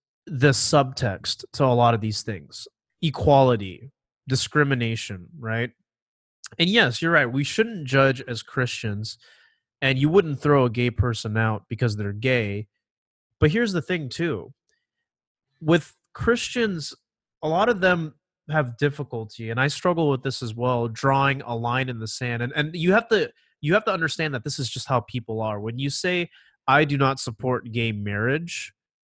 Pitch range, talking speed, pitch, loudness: 115-155 Hz, 170 wpm, 130 Hz, -23 LUFS